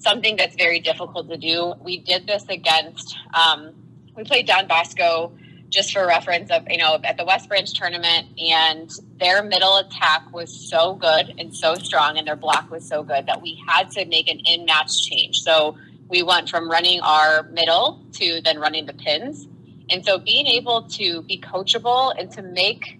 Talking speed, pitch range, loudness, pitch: 190 wpm, 160-185 Hz, -18 LUFS, 170 Hz